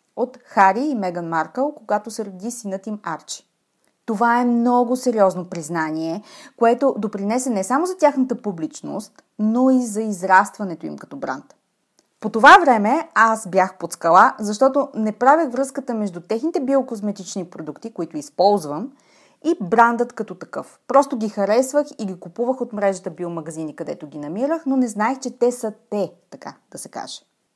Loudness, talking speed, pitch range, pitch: -19 LUFS, 160 wpm, 190-255 Hz, 220 Hz